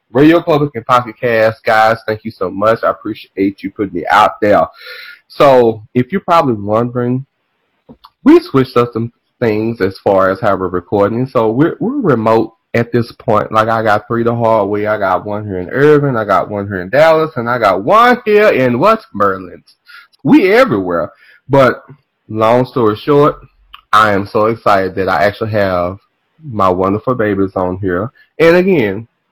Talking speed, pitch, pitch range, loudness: 180 wpm, 115 Hz, 105-140 Hz, -12 LUFS